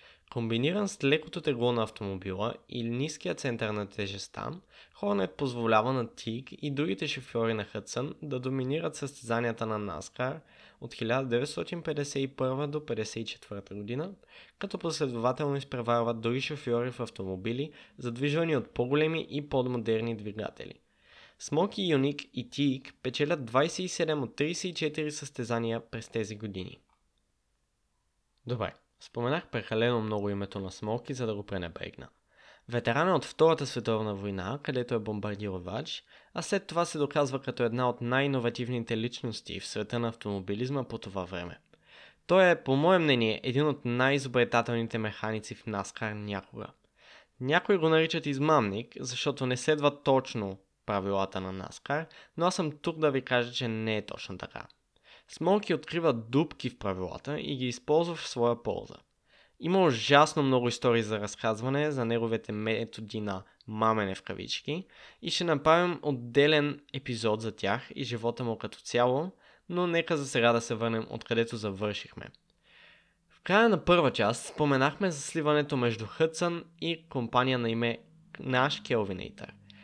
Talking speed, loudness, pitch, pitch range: 140 wpm, -30 LUFS, 125 Hz, 110-150 Hz